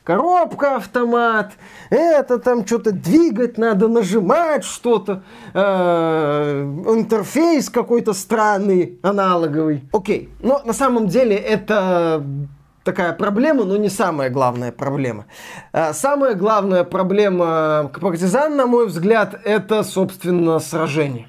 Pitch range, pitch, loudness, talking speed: 170-230 Hz, 205 Hz, -17 LUFS, 110 wpm